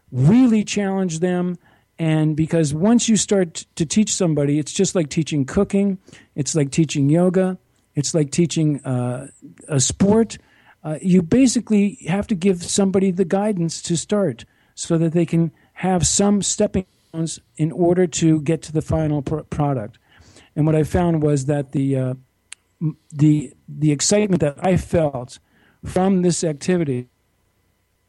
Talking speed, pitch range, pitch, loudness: 155 wpm, 145-185 Hz, 165 Hz, -19 LUFS